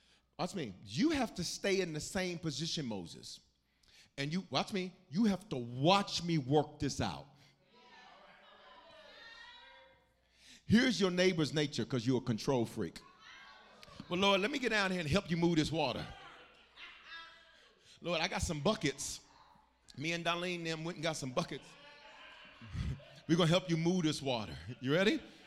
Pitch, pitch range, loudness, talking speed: 170 Hz, 145-195 Hz, -35 LUFS, 165 wpm